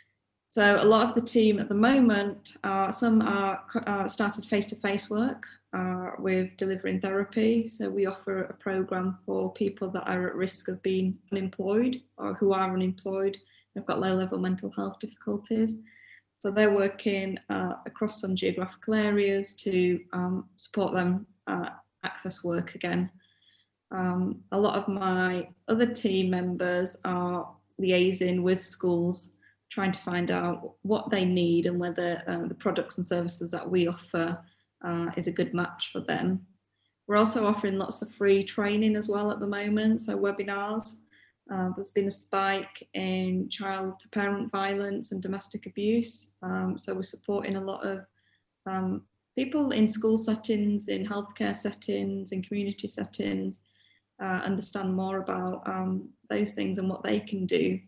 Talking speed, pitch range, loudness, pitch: 160 wpm, 185-205 Hz, -29 LUFS, 195 Hz